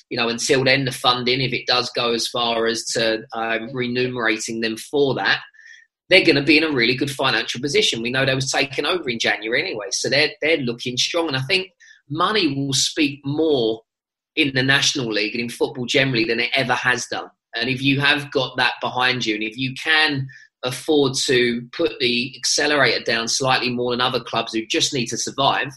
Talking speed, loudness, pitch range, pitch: 210 wpm, -19 LUFS, 120-140 Hz, 125 Hz